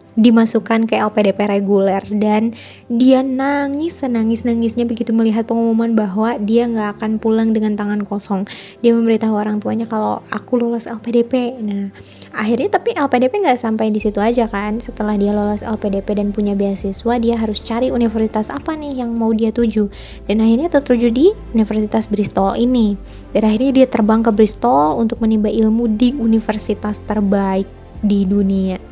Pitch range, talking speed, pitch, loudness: 210-235 Hz, 160 wpm, 225 Hz, -16 LUFS